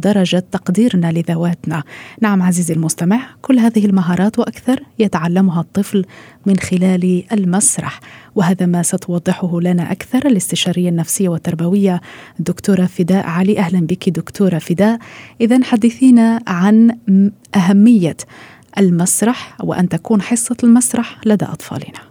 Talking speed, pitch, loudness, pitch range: 110 wpm, 190 Hz, -14 LUFS, 175-215 Hz